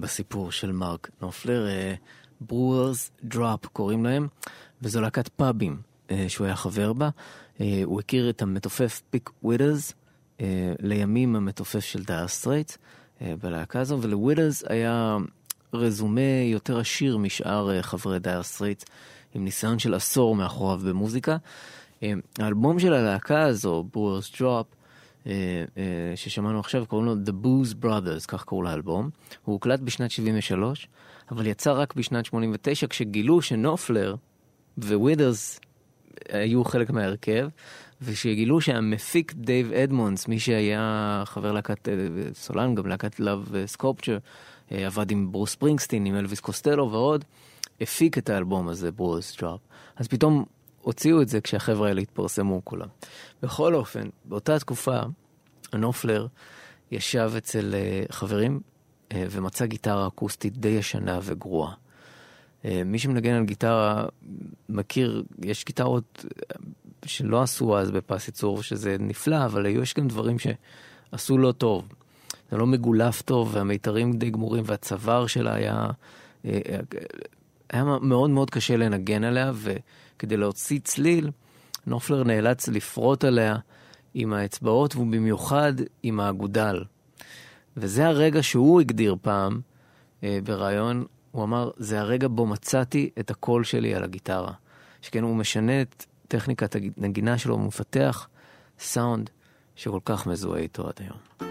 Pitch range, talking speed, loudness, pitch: 100-130 Hz, 130 wpm, -26 LUFS, 115 Hz